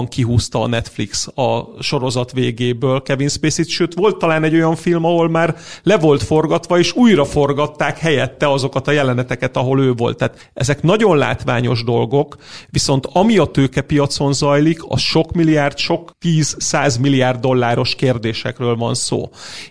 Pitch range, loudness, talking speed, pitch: 125-160 Hz, -16 LUFS, 150 wpm, 140 Hz